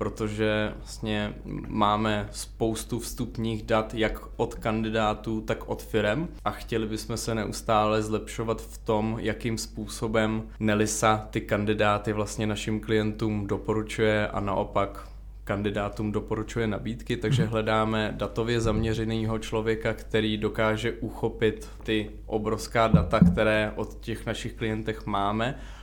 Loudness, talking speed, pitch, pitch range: -28 LUFS, 120 wpm, 110 Hz, 105-115 Hz